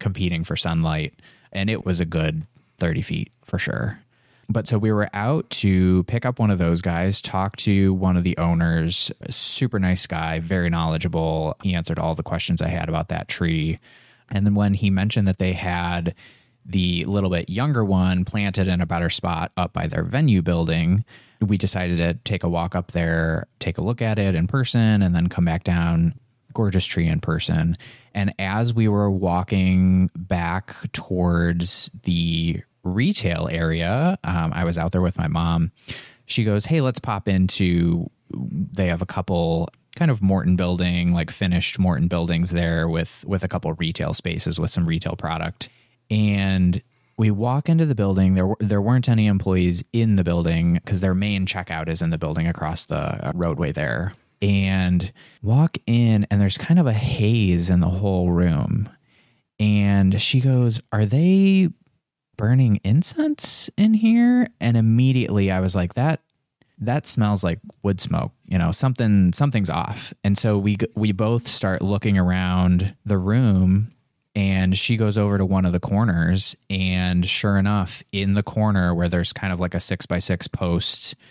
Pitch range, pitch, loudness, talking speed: 85-115 Hz, 95 Hz, -21 LUFS, 175 wpm